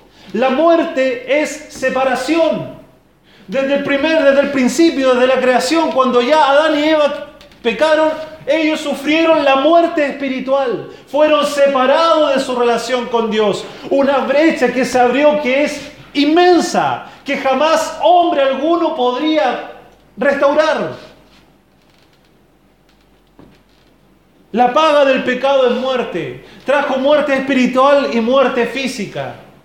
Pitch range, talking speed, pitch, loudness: 255-305 Hz, 115 wpm, 280 Hz, -14 LUFS